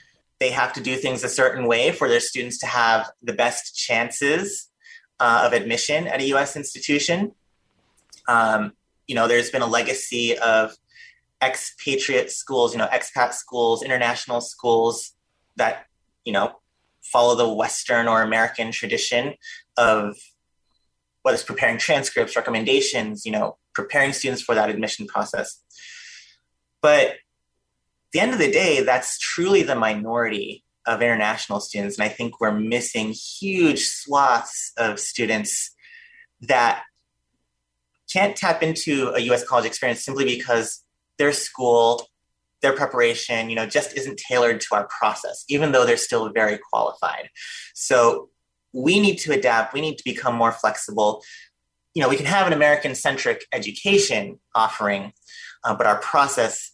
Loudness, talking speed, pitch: -21 LUFS, 145 wpm, 125 Hz